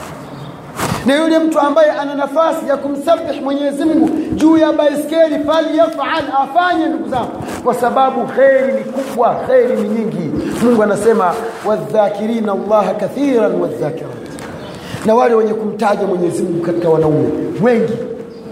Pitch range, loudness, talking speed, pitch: 210-295 Hz, -14 LUFS, 125 wpm, 245 Hz